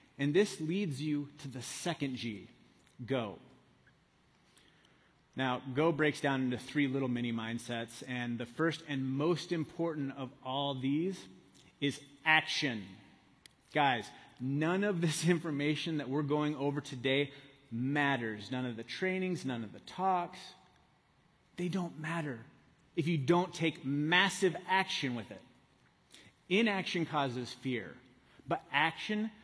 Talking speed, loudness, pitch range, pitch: 130 wpm, -34 LUFS, 130-170 Hz, 145 Hz